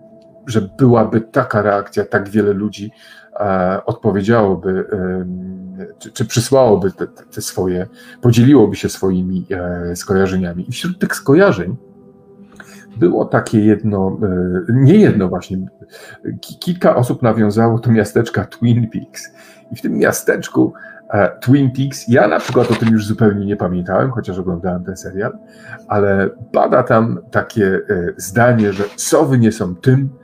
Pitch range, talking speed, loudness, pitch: 95-120 Hz, 140 wpm, -15 LUFS, 105 Hz